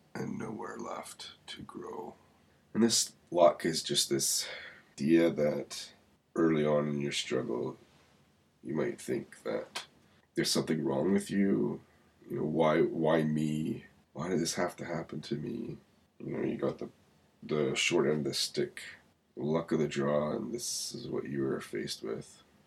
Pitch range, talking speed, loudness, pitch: 70-80 Hz, 165 wpm, -32 LUFS, 75 Hz